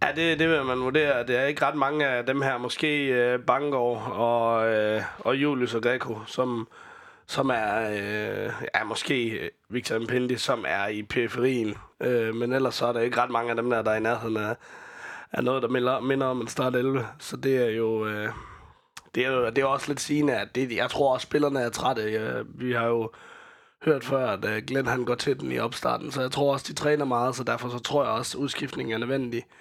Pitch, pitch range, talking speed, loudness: 125 Hz, 115-135 Hz, 225 wpm, -26 LUFS